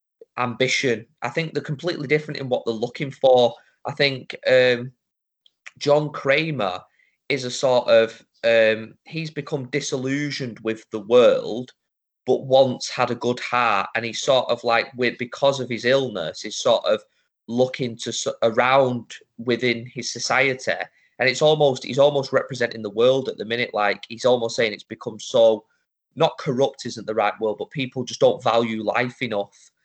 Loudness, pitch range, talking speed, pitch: -22 LUFS, 120-140 Hz, 165 wpm, 125 Hz